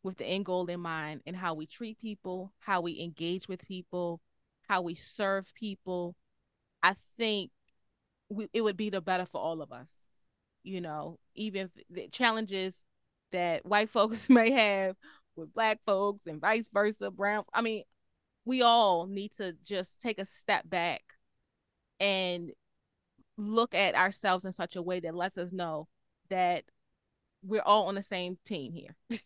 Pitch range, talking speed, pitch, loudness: 175-210 Hz, 165 wpm, 190 Hz, -31 LUFS